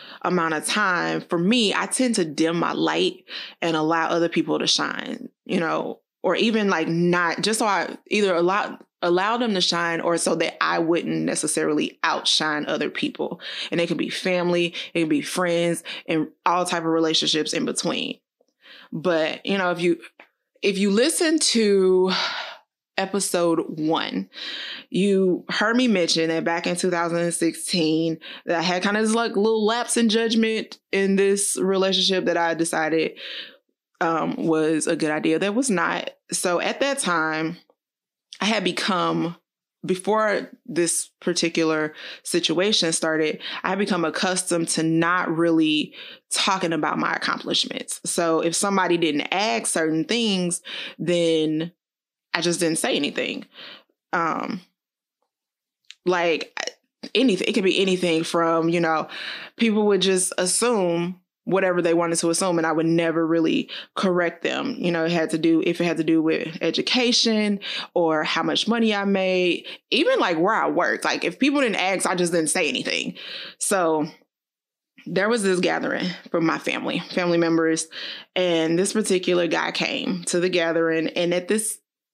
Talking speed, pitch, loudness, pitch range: 160 wpm, 175 Hz, -22 LUFS, 165-200 Hz